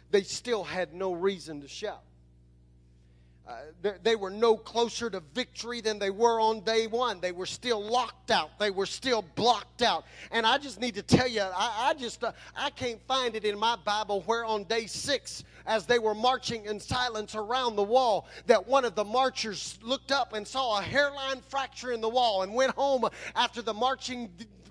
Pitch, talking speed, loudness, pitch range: 225 Hz, 205 wpm, -29 LUFS, 205-250 Hz